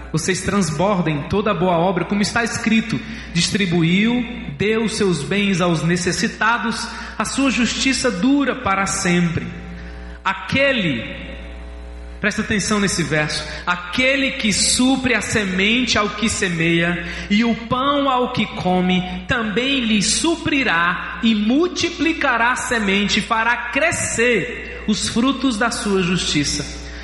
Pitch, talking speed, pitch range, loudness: 210 Hz, 120 wpm, 175-240 Hz, -18 LUFS